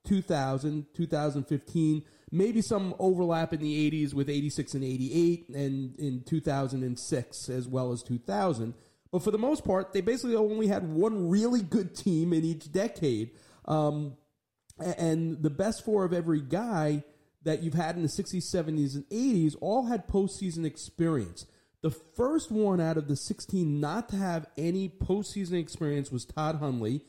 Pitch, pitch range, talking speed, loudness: 160 Hz, 145-190 Hz, 160 wpm, -30 LUFS